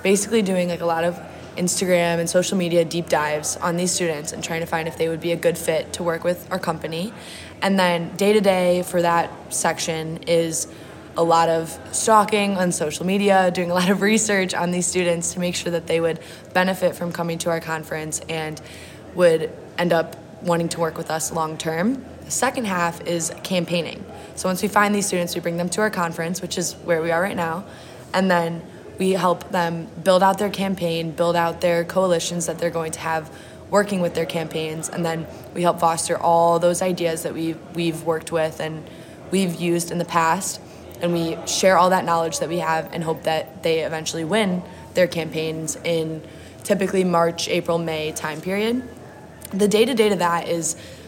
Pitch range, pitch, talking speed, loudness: 165-185 Hz, 170 Hz, 205 wpm, -21 LUFS